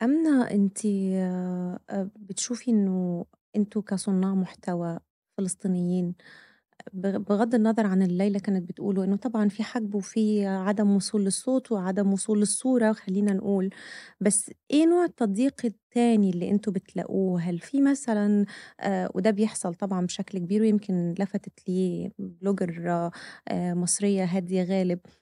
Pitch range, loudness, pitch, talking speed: 185-220 Hz, -26 LUFS, 200 Hz, 120 wpm